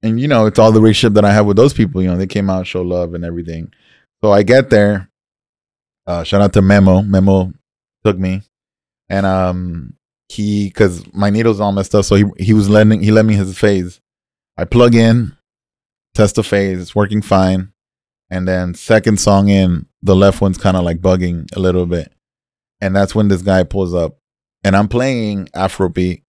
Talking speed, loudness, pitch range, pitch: 200 wpm, -13 LUFS, 90-105 Hz, 100 Hz